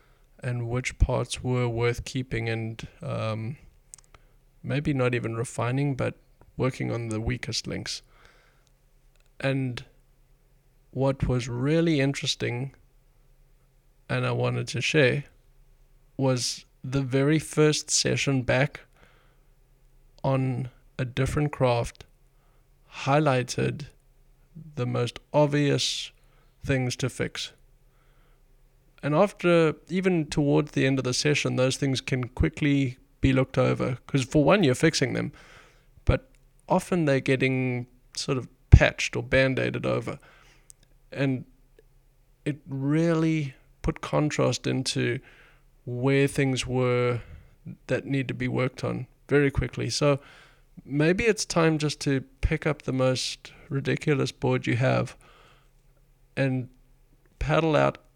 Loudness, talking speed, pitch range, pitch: -26 LUFS, 115 wpm, 125-140 Hz, 135 Hz